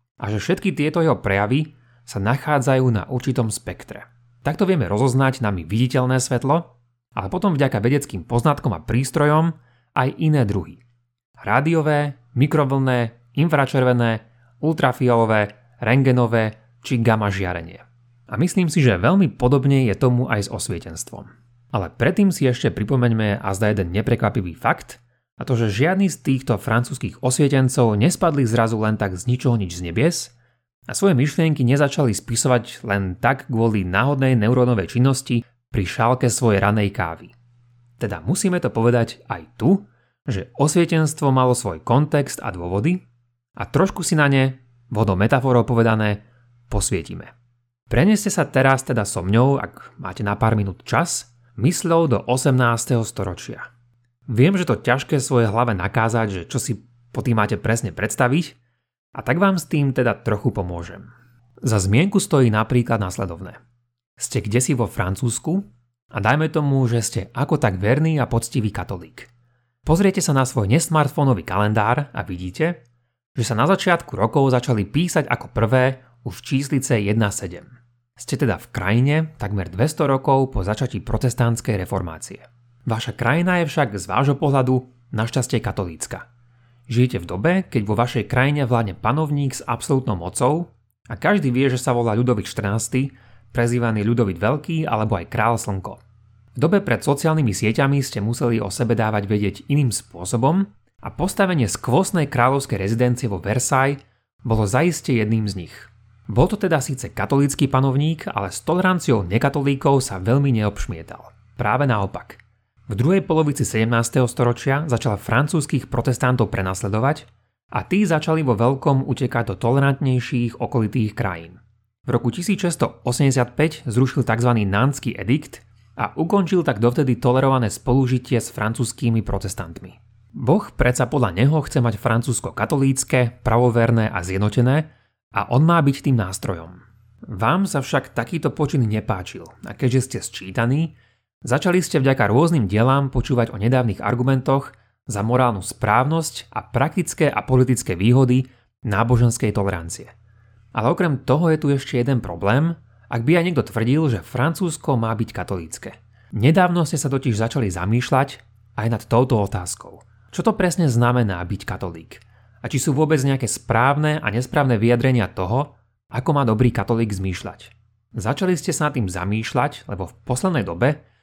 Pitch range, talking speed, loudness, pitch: 110-140 Hz, 145 wpm, -20 LUFS, 120 Hz